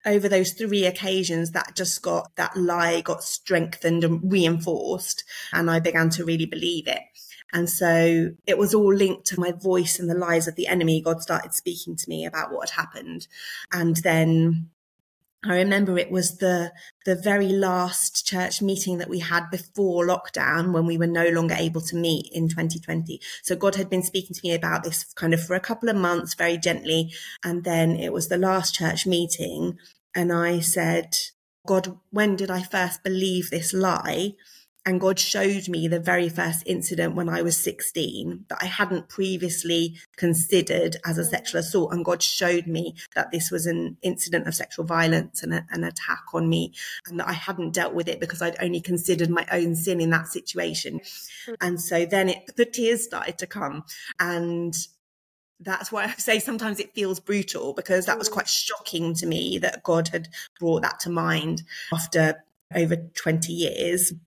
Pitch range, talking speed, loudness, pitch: 165-185 Hz, 185 wpm, -24 LUFS, 175 Hz